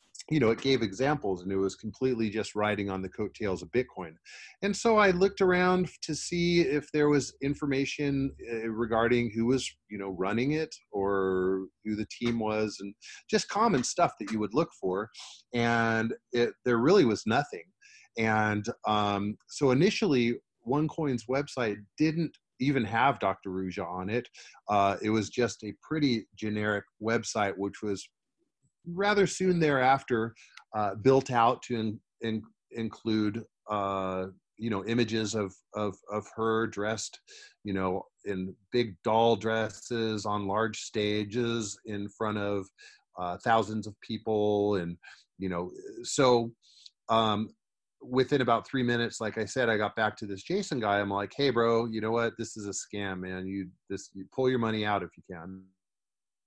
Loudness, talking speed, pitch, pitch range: -29 LUFS, 165 wpm, 110 Hz, 100-130 Hz